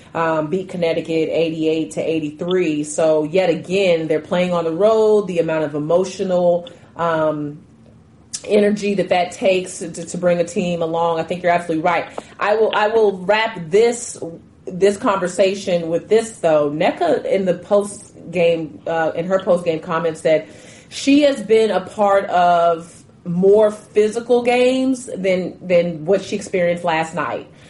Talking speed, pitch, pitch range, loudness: 155 wpm, 175 Hz, 165-200 Hz, -18 LUFS